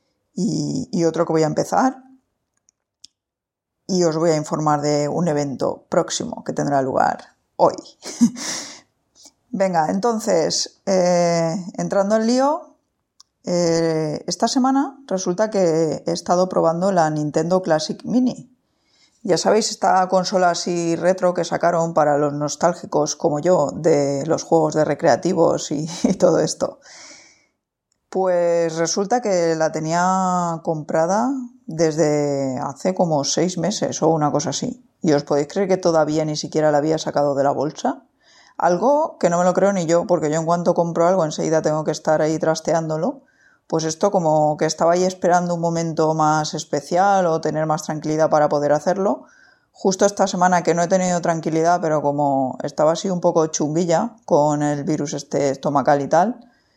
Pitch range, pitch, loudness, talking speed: 155-190 Hz, 170 Hz, -19 LUFS, 155 wpm